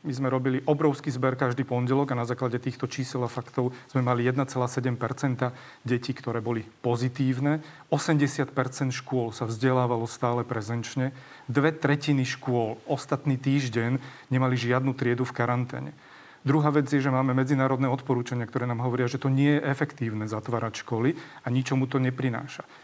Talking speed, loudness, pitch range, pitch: 150 wpm, -27 LUFS, 125-140 Hz, 130 Hz